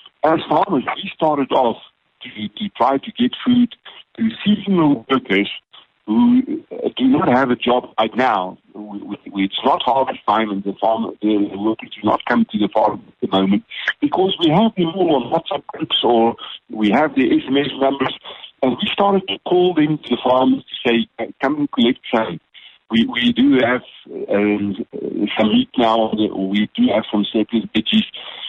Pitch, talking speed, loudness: 135 Hz, 180 wpm, -18 LUFS